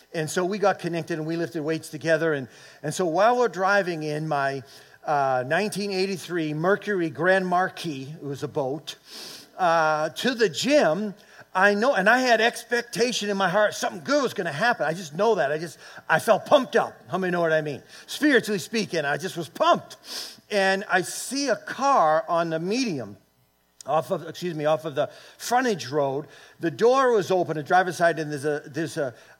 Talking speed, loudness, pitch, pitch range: 200 wpm, -24 LUFS, 175 Hz, 155-205 Hz